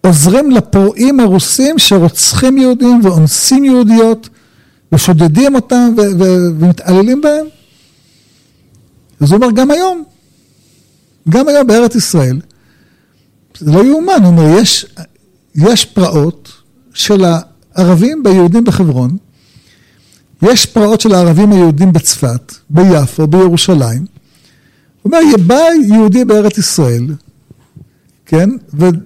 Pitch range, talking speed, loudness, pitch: 155-230 Hz, 105 wpm, -8 LUFS, 185 Hz